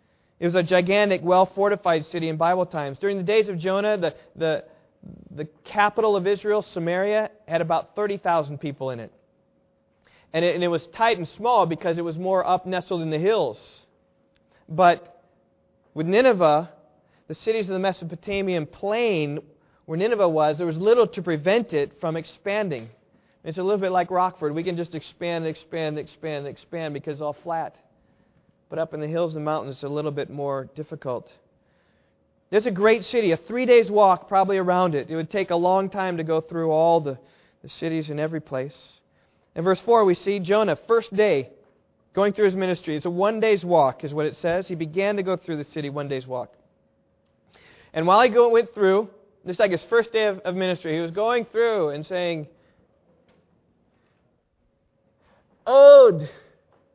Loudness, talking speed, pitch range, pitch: -22 LUFS, 185 wpm, 155-200 Hz, 175 Hz